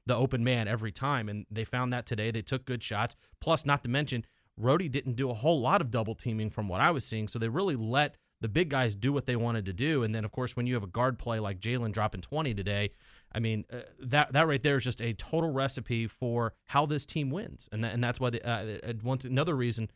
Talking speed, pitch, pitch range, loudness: 260 wpm, 120 Hz, 110-135 Hz, -31 LUFS